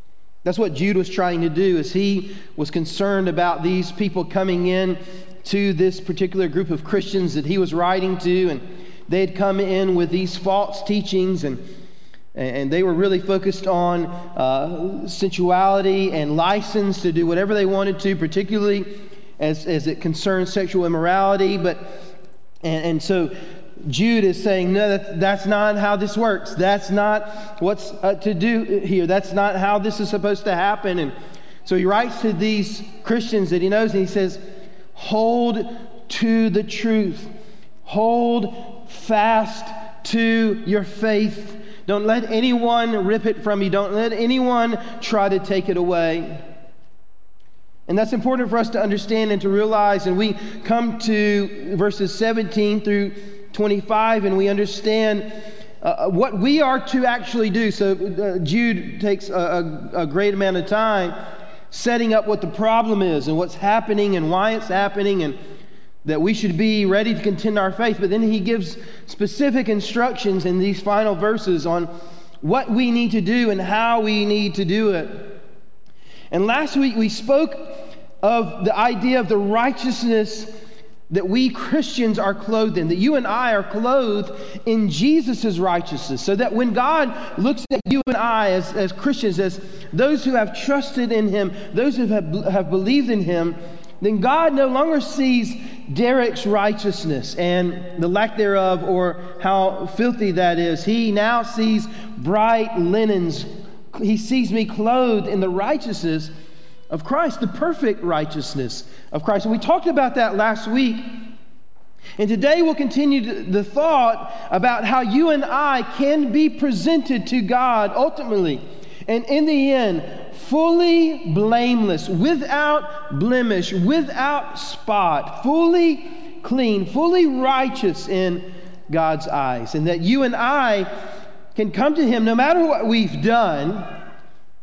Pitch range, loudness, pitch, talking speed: 185-230 Hz, -20 LUFS, 205 Hz, 155 wpm